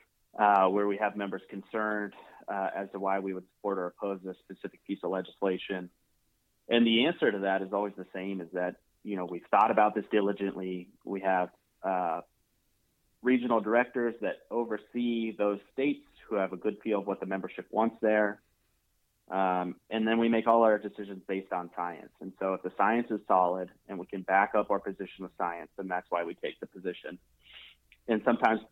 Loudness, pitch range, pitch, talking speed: -31 LUFS, 95-110 Hz, 100 Hz, 195 wpm